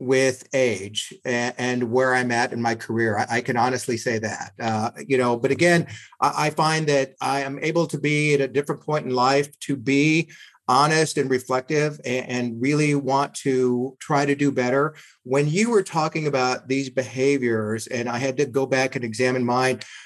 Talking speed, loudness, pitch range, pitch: 185 wpm, -22 LUFS, 125-145 Hz, 135 Hz